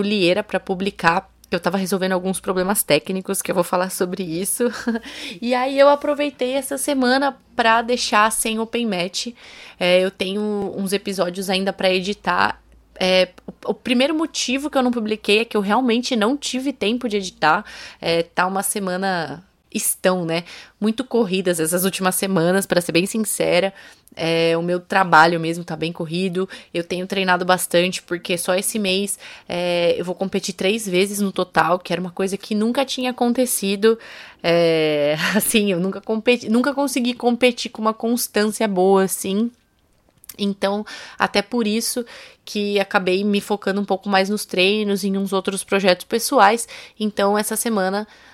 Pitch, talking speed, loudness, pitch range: 200 Hz, 165 wpm, -20 LUFS, 185-230 Hz